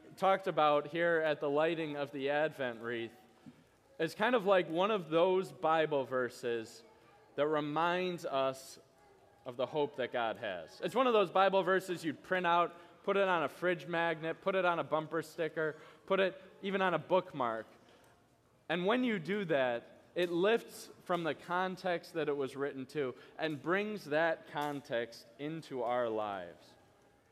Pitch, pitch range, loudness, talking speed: 160 Hz, 145-185 Hz, -34 LUFS, 170 wpm